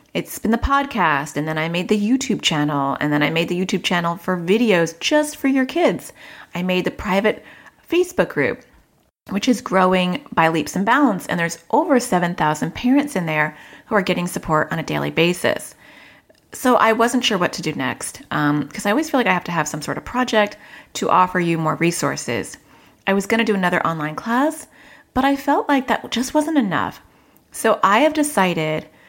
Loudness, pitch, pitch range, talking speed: -19 LUFS, 195 Hz, 170-255 Hz, 205 wpm